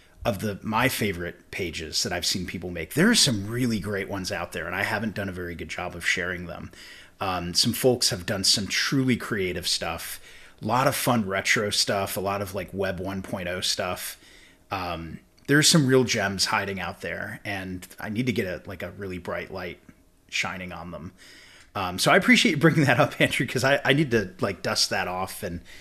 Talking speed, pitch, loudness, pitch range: 215 wpm, 100 Hz, -24 LUFS, 90-120 Hz